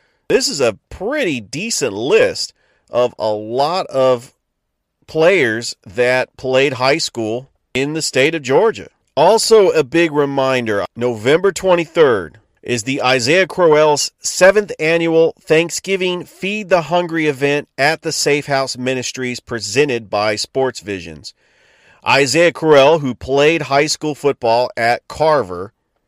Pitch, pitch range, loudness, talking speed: 140 Hz, 125-170 Hz, -15 LUFS, 125 wpm